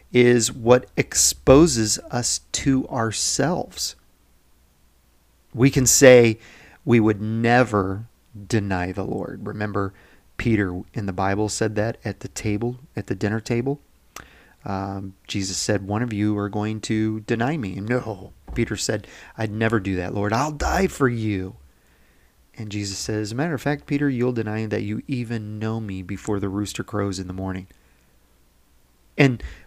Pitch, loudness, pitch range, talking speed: 105 Hz, -22 LUFS, 95-115 Hz, 155 wpm